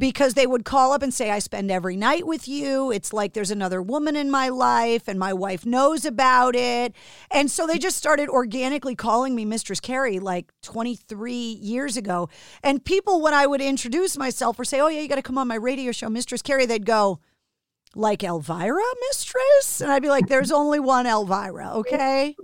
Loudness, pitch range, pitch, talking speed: -22 LUFS, 220-280 Hz, 255 Hz, 205 wpm